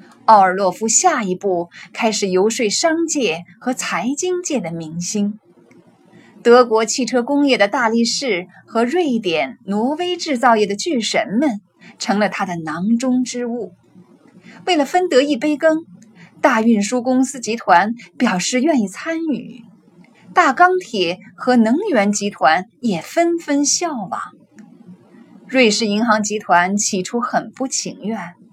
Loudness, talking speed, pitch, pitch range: -17 LUFS, 200 characters per minute, 225 Hz, 200-265 Hz